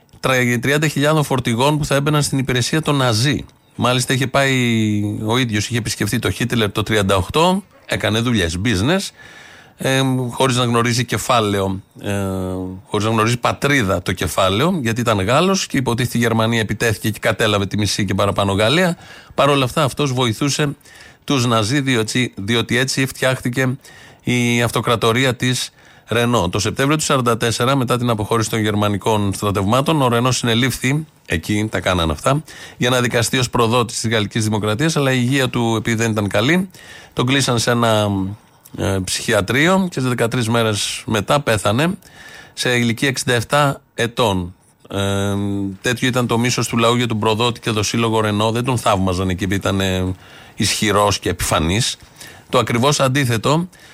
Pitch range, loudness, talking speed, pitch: 105-130 Hz, -17 LUFS, 150 wpm, 120 Hz